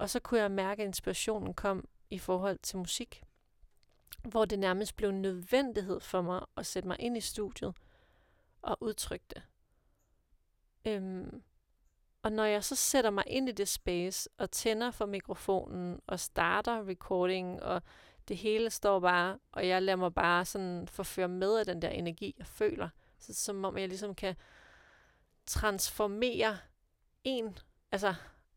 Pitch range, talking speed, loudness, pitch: 185-220 Hz, 160 wpm, -34 LUFS, 195 Hz